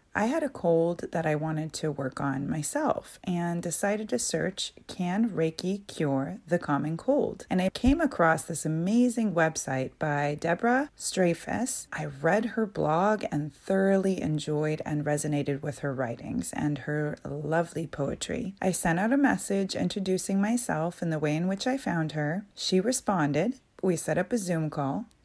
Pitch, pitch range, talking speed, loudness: 170 Hz, 150-200 Hz, 165 wpm, -28 LUFS